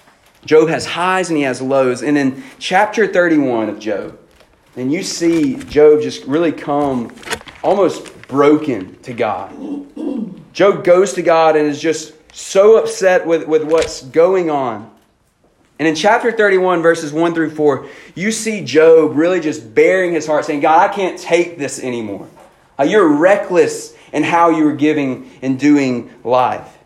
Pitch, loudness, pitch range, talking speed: 165 Hz, -14 LUFS, 150-200 Hz, 160 wpm